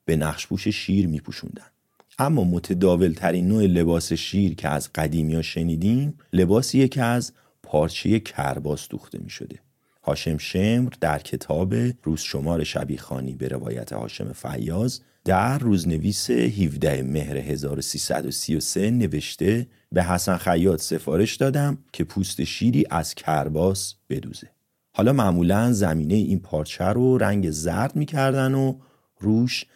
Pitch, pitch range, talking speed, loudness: 95 Hz, 80-115 Hz, 130 wpm, -23 LUFS